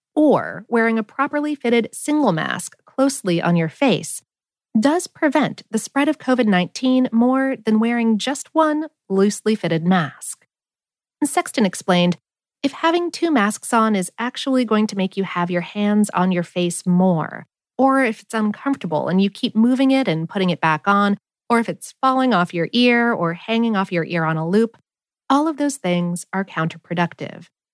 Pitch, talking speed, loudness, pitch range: 220 Hz, 175 wpm, -19 LUFS, 180-265 Hz